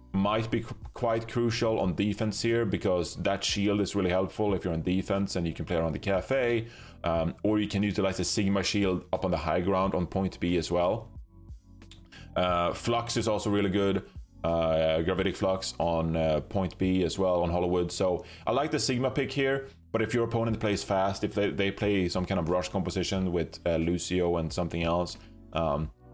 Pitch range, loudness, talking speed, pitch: 85-105 Hz, -29 LUFS, 205 wpm, 95 Hz